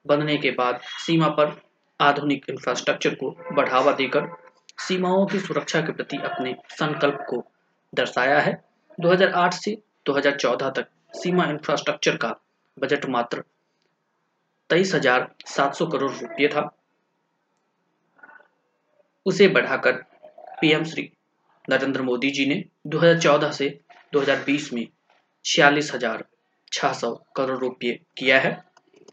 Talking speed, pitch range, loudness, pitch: 105 wpm, 140-180 Hz, -23 LUFS, 150 Hz